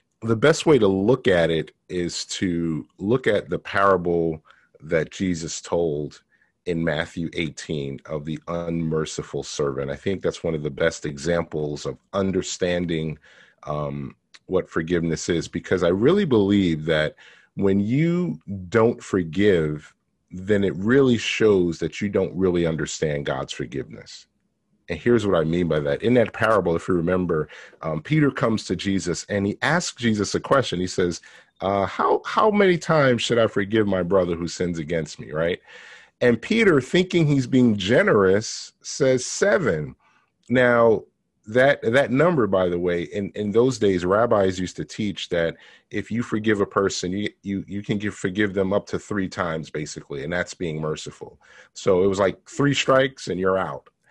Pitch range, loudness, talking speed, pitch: 85-115 Hz, -22 LUFS, 170 wpm, 95 Hz